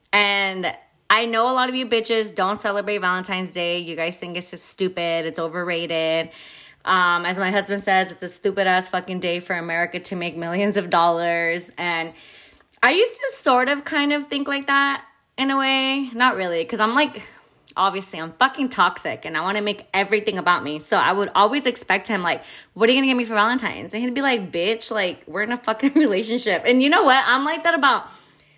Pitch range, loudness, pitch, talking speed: 175-250 Hz, -20 LUFS, 200 Hz, 215 wpm